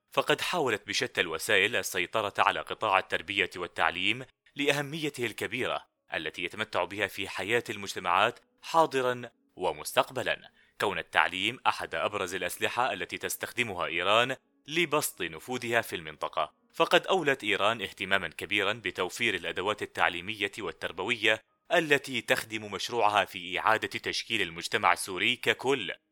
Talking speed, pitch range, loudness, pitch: 115 wpm, 110-150 Hz, -29 LUFS, 125 Hz